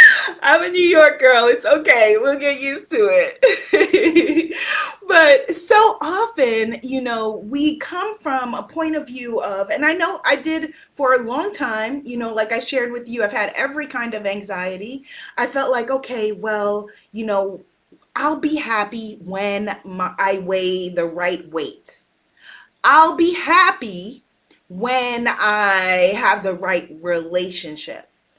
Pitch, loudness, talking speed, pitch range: 255 Hz, -17 LUFS, 155 wpm, 205-320 Hz